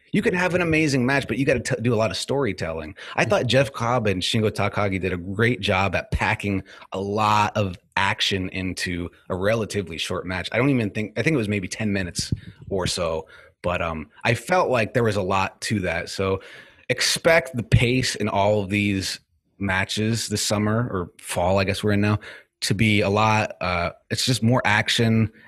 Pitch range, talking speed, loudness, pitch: 95-115 Hz, 205 wpm, -23 LUFS, 105 Hz